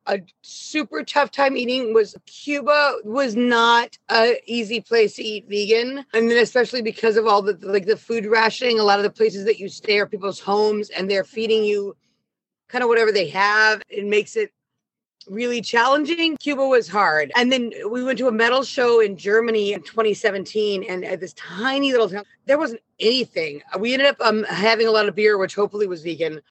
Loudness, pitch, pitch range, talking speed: -20 LUFS, 225 Hz, 205-245 Hz, 200 wpm